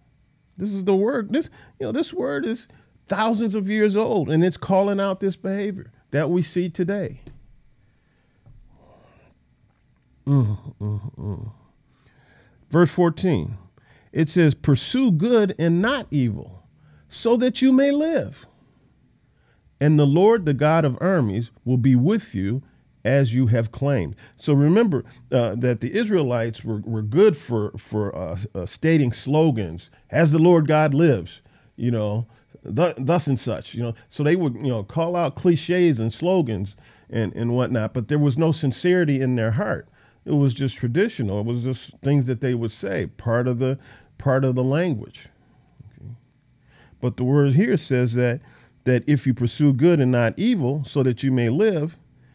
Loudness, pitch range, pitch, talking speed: -21 LUFS, 120-175 Hz, 140 Hz, 165 wpm